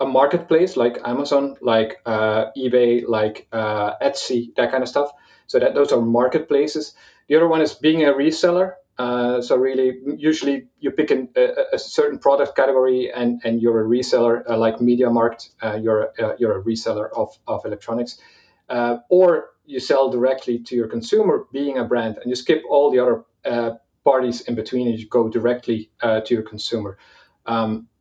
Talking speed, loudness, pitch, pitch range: 185 wpm, -20 LUFS, 125 Hz, 115-145 Hz